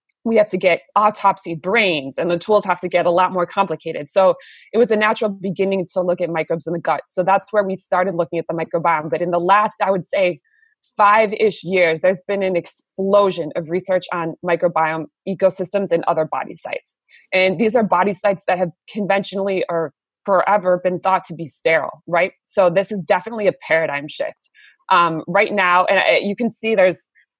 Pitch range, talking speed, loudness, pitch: 170-200 Hz, 200 wpm, -18 LUFS, 185 Hz